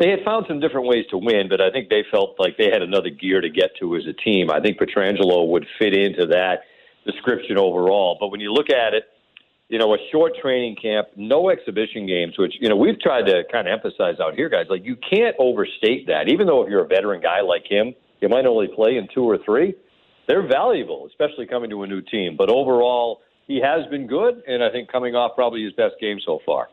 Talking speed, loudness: 240 wpm, -20 LUFS